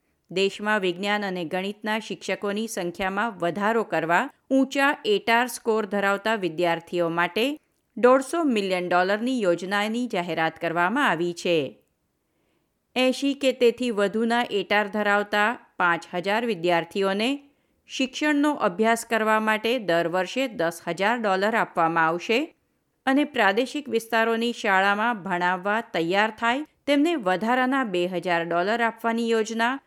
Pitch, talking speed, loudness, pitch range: 215 Hz, 115 wpm, -24 LUFS, 180-240 Hz